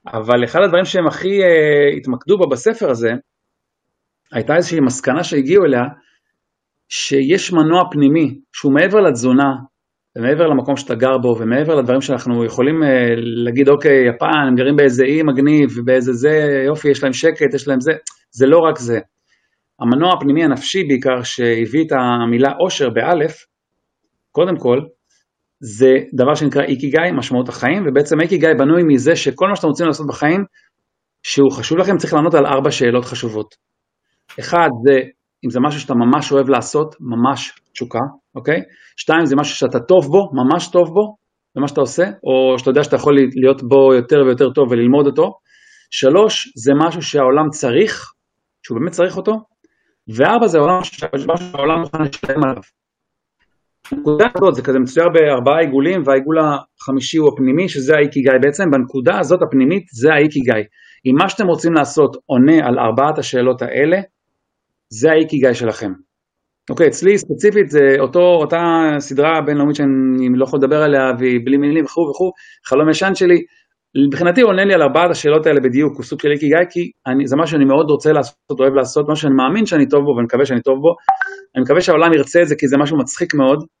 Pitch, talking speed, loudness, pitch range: 145 Hz, 165 wpm, -14 LUFS, 130-170 Hz